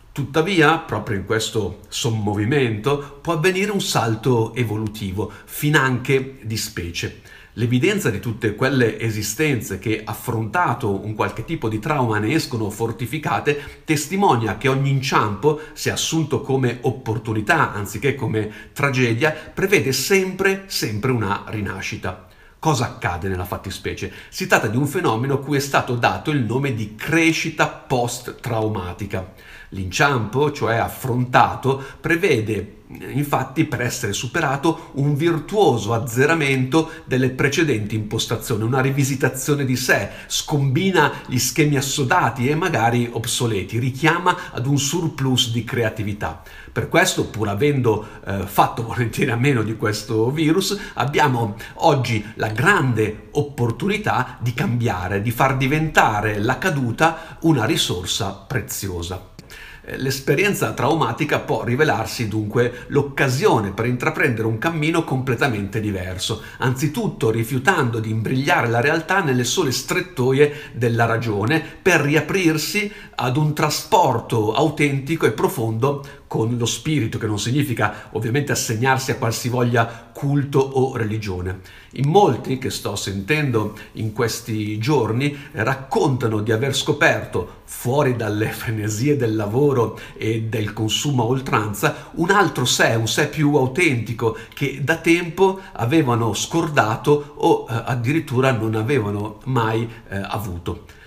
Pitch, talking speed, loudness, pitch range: 125 Hz, 125 wpm, -20 LUFS, 110-145 Hz